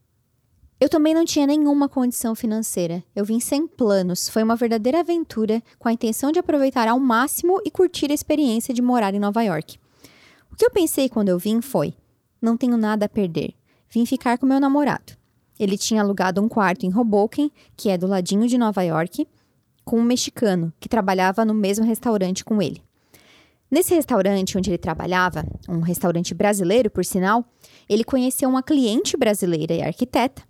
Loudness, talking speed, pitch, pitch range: -21 LUFS, 175 wpm, 225 Hz, 195-265 Hz